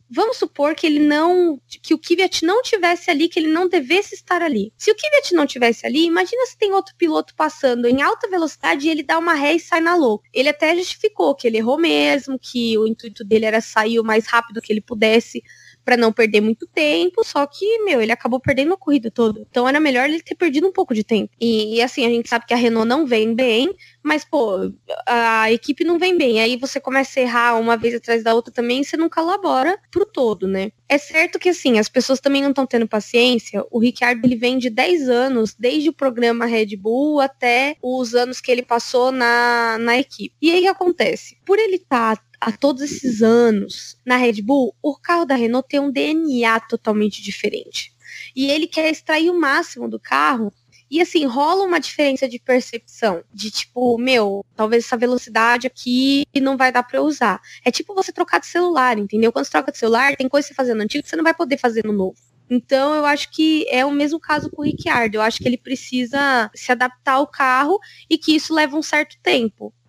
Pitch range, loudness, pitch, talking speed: 235-320 Hz, -18 LUFS, 260 Hz, 220 wpm